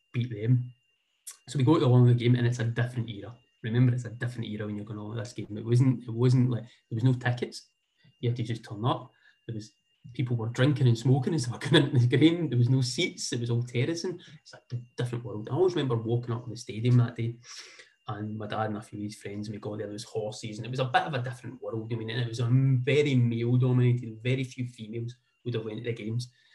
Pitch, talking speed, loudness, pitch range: 120 Hz, 265 wpm, -28 LUFS, 115-130 Hz